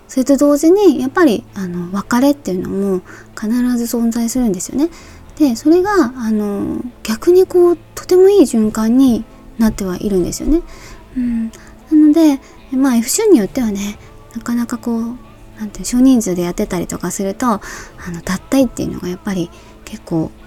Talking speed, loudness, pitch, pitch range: 335 characters per minute, -15 LUFS, 240 Hz, 200-290 Hz